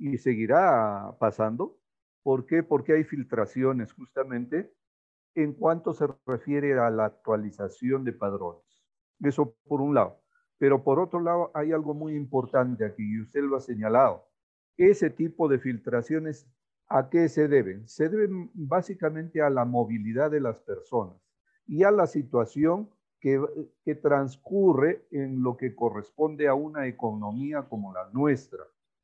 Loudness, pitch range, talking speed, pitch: -27 LUFS, 120-155 Hz, 145 wpm, 140 Hz